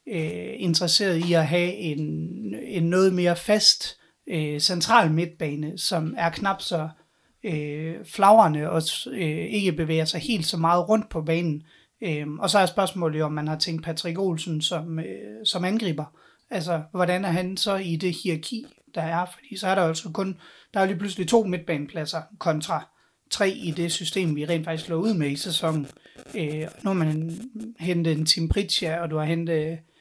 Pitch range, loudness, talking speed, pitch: 160-190 Hz, -24 LUFS, 190 wpm, 170 Hz